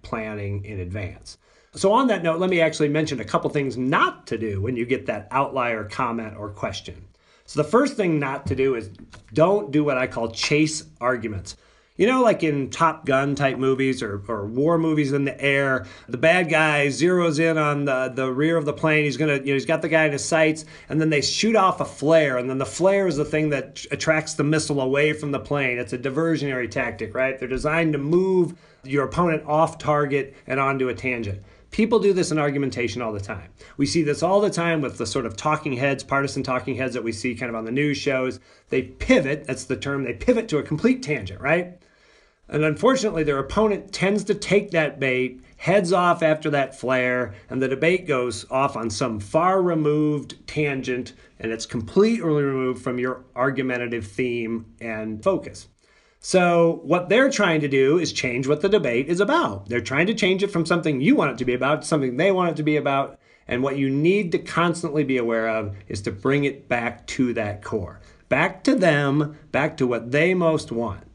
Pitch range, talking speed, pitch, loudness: 125-160 Hz, 215 wpm, 140 Hz, -22 LUFS